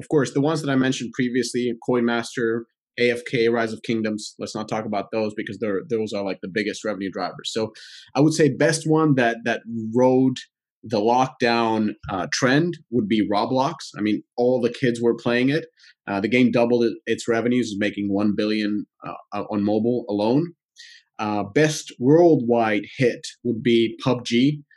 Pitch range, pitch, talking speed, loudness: 110-130 Hz, 120 Hz, 175 wpm, -22 LUFS